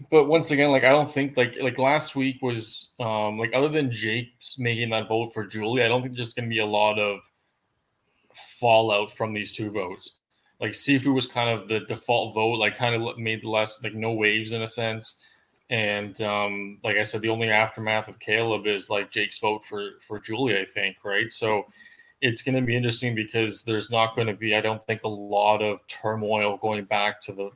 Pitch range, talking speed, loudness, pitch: 105-120 Hz, 220 wpm, -25 LUFS, 110 Hz